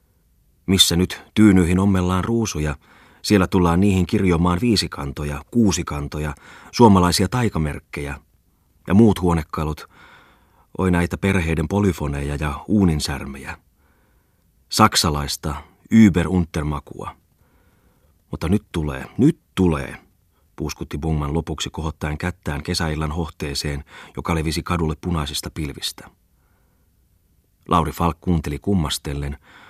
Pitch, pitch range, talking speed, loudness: 85 Hz, 75-90 Hz, 90 wpm, -20 LUFS